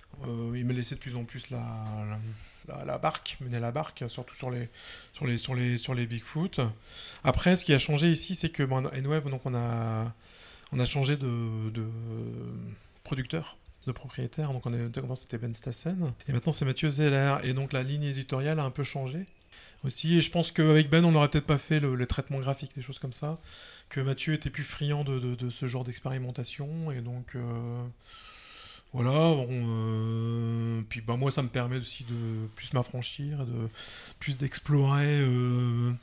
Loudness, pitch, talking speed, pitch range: -30 LUFS, 130 Hz, 195 wpm, 120-145 Hz